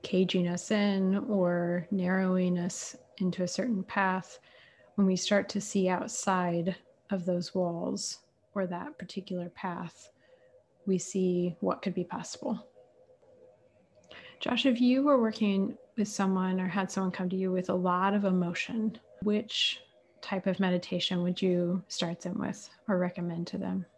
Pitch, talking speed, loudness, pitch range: 190 Hz, 150 wpm, -31 LUFS, 180-205 Hz